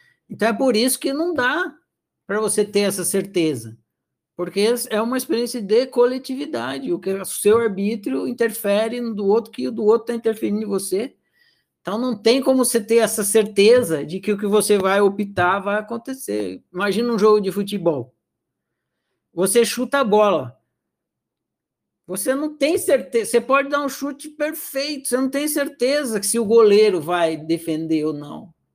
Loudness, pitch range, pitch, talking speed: -20 LUFS, 195-255 Hz, 220 Hz, 175 wpm